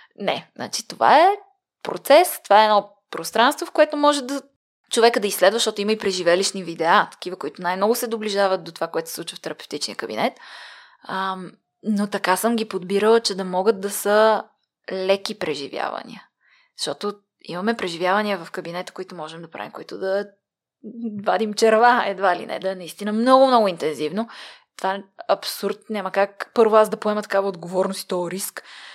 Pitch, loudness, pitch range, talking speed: 205 Hz, -21 LUFS, 190-225 Hz, 170 wpm